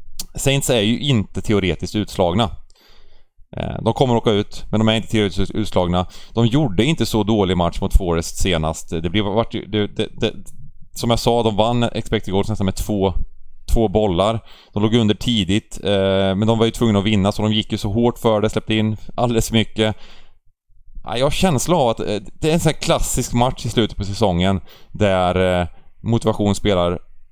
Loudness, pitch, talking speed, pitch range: -19 LUFS, 105 Hz, 190 wpm, 95-115 Hz